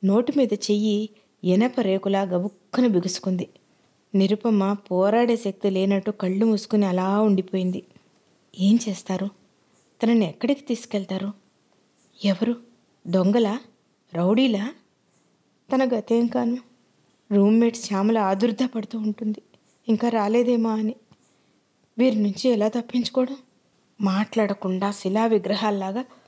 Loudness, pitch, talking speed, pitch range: -23 LUFS, 215 Hz, 90 wpm, 195-235 Hz